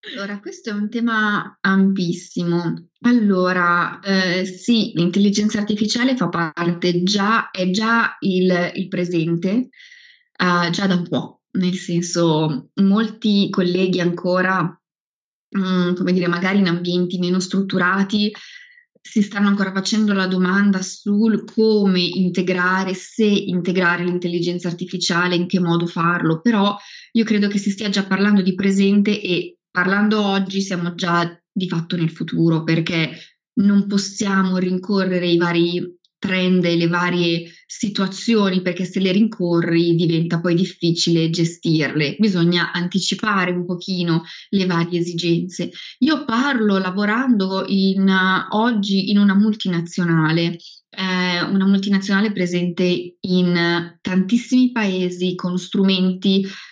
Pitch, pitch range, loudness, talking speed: 185 Hz, 175-200 Hz, -19 LUFS, 125 wpm